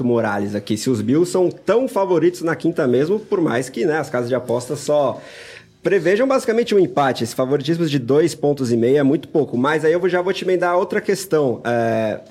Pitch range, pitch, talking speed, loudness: 125-185 Hz, 155 Hz, 215 wpm, -18 LUFS